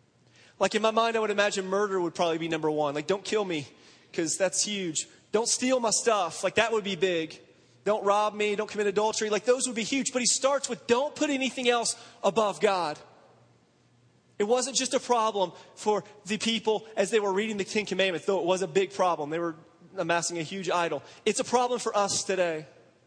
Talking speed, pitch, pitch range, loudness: 215 wpm, 205 Hz, 180-225 Hz, -27 LUFS